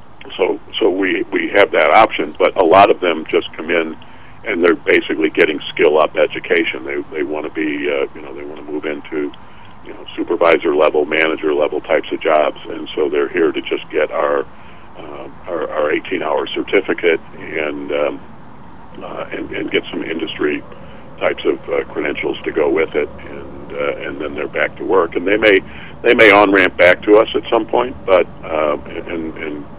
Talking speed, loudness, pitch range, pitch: 200 wpm, -16 LUFS, 345-440 Hz, 395 Hz